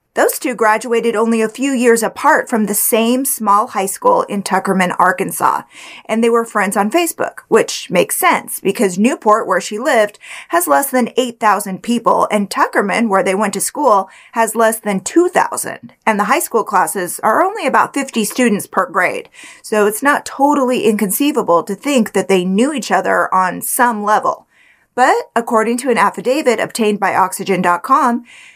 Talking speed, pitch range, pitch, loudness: 170 wpm, 205-265 Hz, 225 Hz, -14 LUFS